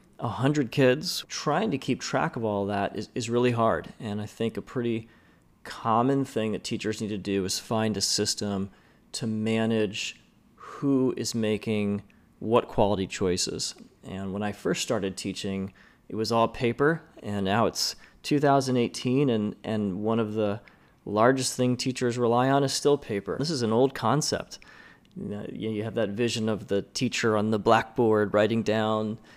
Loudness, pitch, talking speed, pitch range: -27 LUFS, 110 Hz, 170 wpm, 105-125 Hz